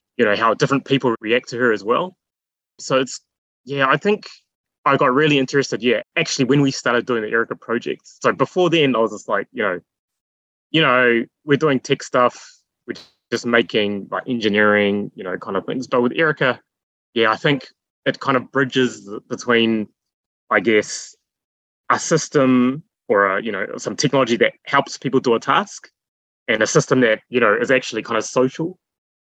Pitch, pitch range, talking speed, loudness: 125 Hz, 110-140 Hz, 185 wpm, -19 LUFS